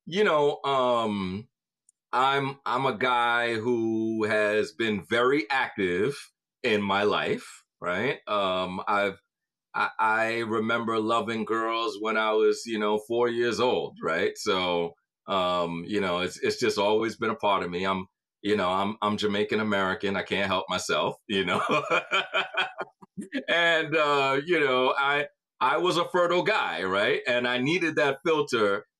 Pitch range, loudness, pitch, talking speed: 105-140 Hz, -26 LUFS, 115 Hz, 155 wpm